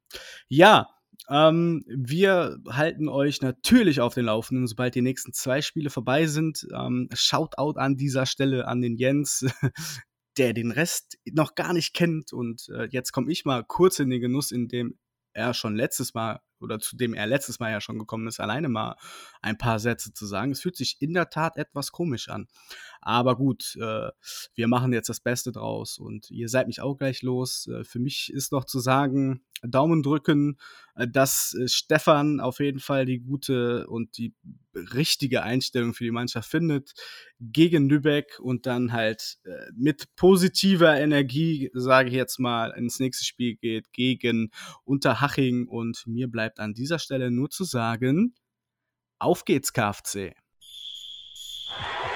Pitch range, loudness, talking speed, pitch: 120-145 Hz, -25 LUFS, 160 wpm, 130 Hz